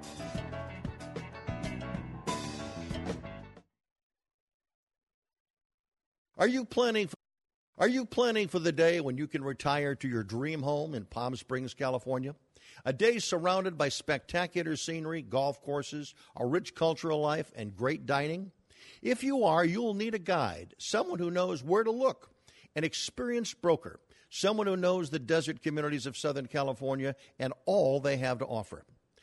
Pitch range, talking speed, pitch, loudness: 130-180 Hz, 140 wpm, 150 Hz, -32 LUFS